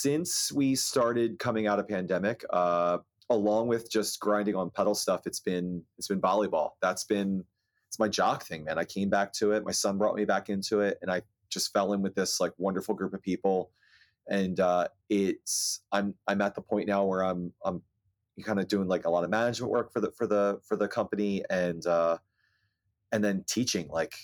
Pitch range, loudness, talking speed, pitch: 95-105 Hz, -29 LUFS, 210 wpm, 100 Hz